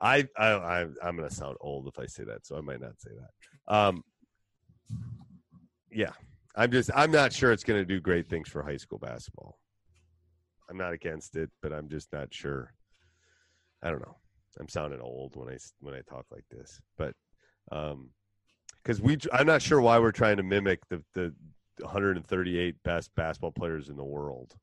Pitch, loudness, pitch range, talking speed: 90 Hz, -29 LUFS, 75-105 Hz, 190 wpm